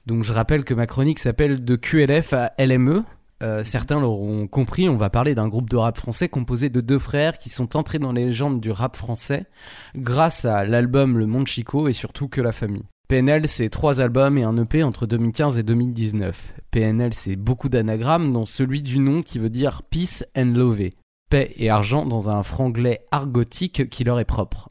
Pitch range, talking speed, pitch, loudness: 115-140 Hz, 205 wpm, 125 Hz, -21 LUFS